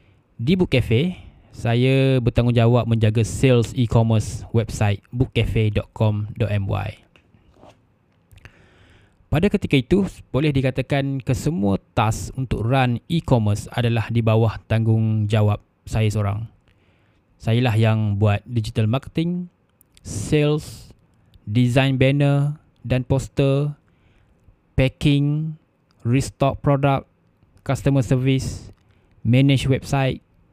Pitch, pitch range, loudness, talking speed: 115 Hz, 105-135 Hz, -21 LUFS, 85 wpm